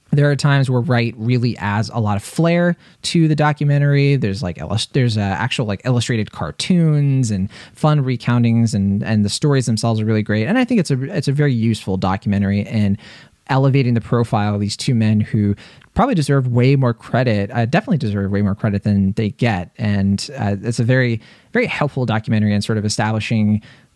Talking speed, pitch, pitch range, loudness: 195 wpm, 115 Hz, 105-140 Hz, -18 LUFS